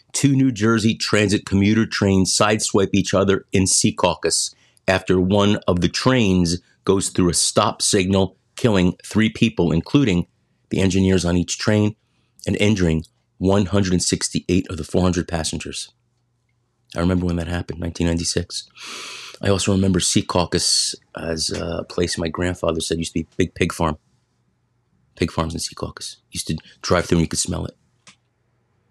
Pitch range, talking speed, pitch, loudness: 85-105 Hz, 155 wpm, 95 Hz, -20 LUFS